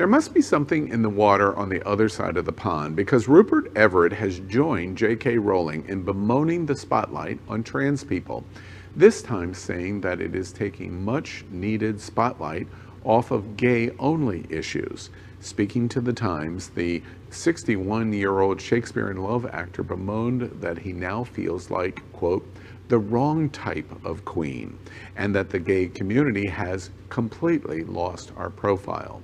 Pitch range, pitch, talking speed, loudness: 95-120 Hz, 105 Hz, 155 wpm, -24 LUFS